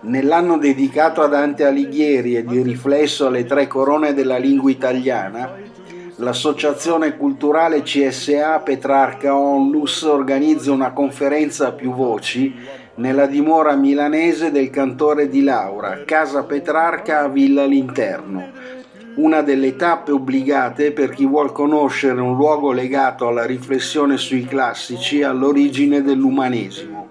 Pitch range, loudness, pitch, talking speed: 135-150 Hz, -17 LUFS, 140 Hz, 120 wpm